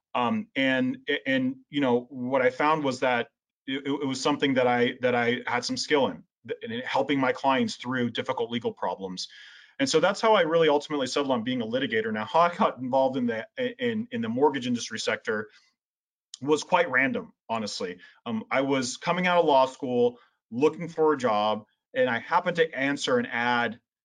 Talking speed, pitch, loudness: 195 wpm, 145 Hz, -26 LUFS